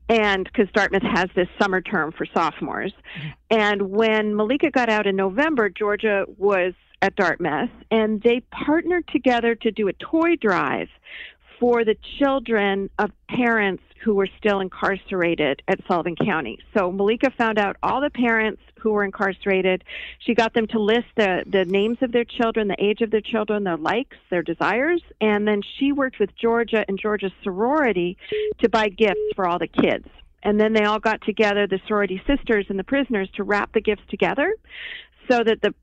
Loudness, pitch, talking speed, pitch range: -22 LUFS, 215 Hz, 180 wpm, 195-235 Hz